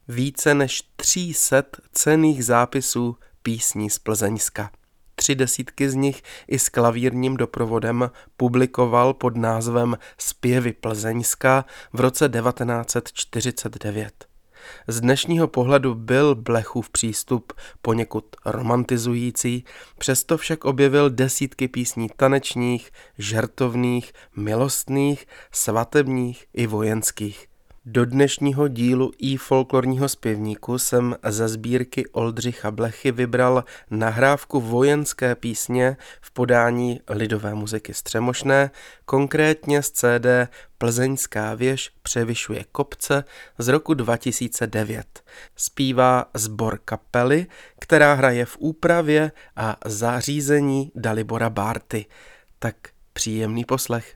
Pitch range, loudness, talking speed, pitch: 115-135 Hz, -21 LUFS, 100 wpm, 125 Hz